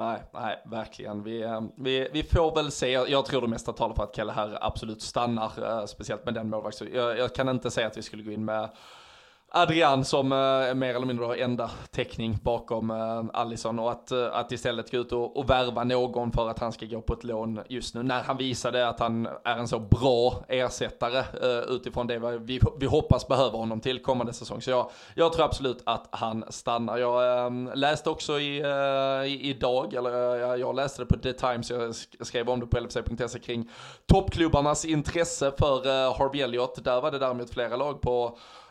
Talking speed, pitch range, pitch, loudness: 205 wpm, 115-130 Hz, 125 Hz, -28 LUFS